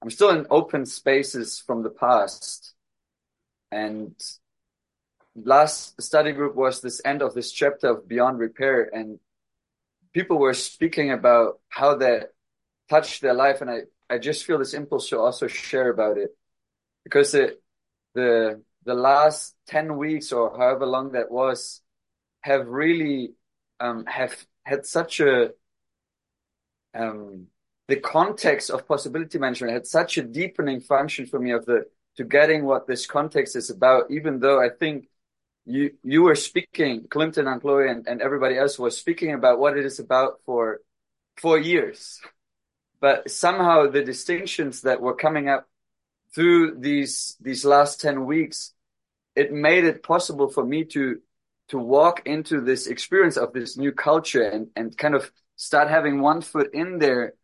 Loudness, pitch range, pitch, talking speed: -22 LUFS, 130-165 Hz, 145 Hz, 155 wpm